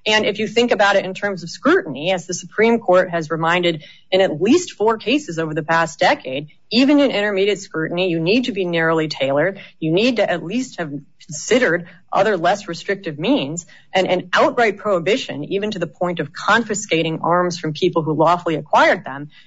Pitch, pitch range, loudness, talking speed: 180 Hz, 165-205 Hz, -18 LUFS, 195 wpm